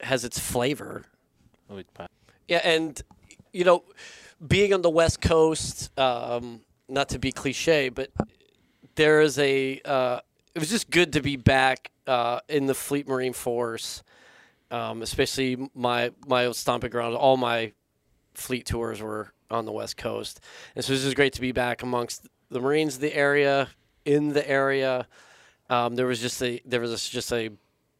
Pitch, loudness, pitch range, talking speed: 130 Hz, -25 LUFS, 120-145 Hz, 165 wpm